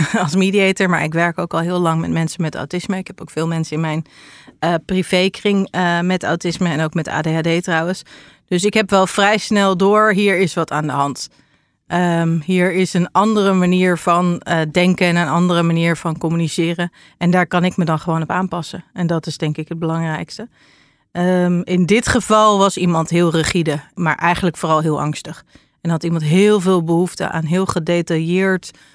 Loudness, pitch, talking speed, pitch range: -17 LUFS, 175 Hz, 200 wpm, 165-185 Hz